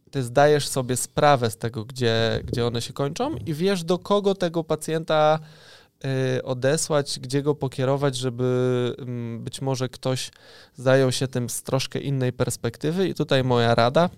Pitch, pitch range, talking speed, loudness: 135 Hz, 125-150 Hz, 150 wpm, -23 LUFS